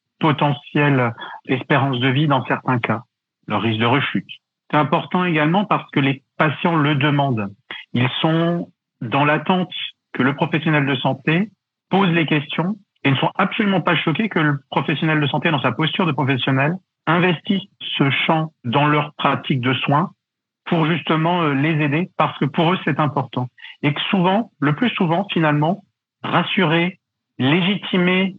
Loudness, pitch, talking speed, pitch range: -19 LUFS, 155 Hz, 160 wpm, 140-175 Hz